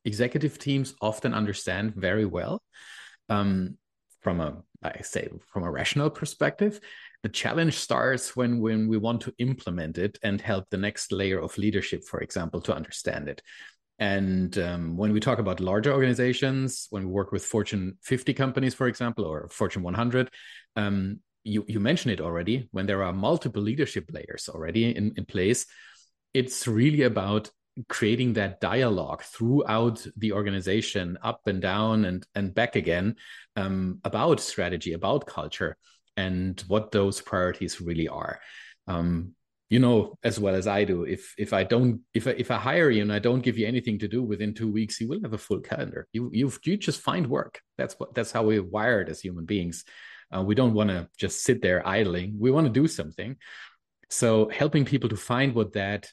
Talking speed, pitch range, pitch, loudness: 185 wpm, 95-125 Hz, 110 Hz, -27 LUFS